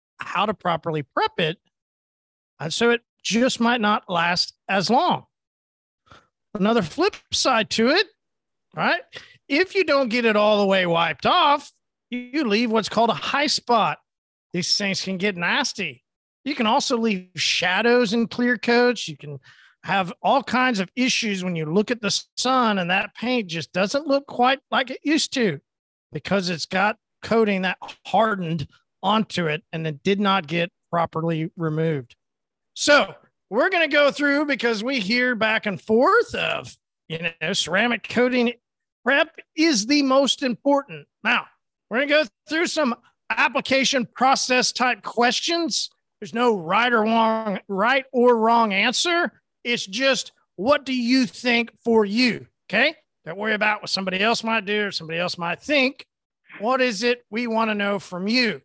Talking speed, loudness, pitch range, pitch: 165 wpm, -21 LUFS, 185-255 Hz, 225 Hz